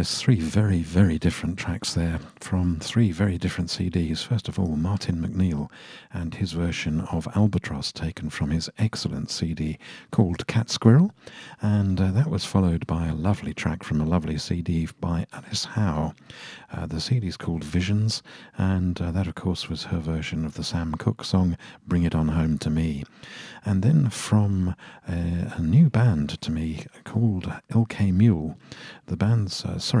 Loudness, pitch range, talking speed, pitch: -25 LUFS, 80-105 Hz, 175 wpm, 90 Hz